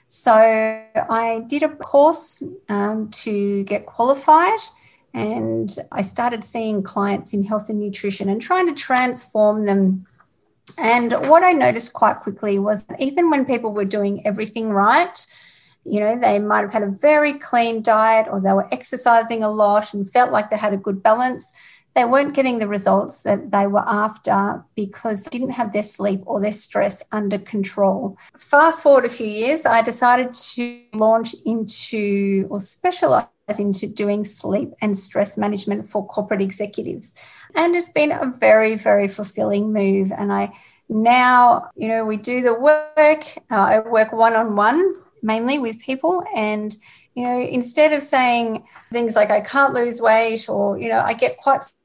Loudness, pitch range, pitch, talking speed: -18 LUFS, 205-255 Hz, 220 Hz, 170 wpm